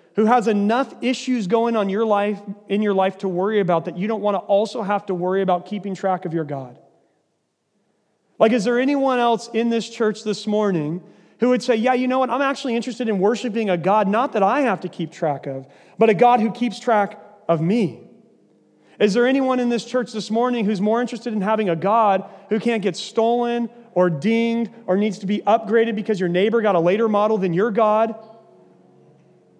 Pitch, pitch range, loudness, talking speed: 215 Hz, 195-230 Hz, -20 LUFS, 215 wpm